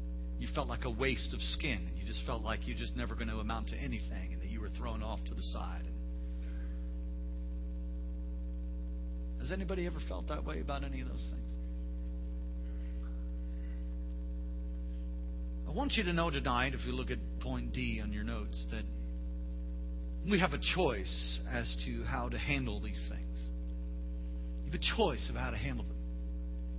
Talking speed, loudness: 170 wpm, -38 LUFS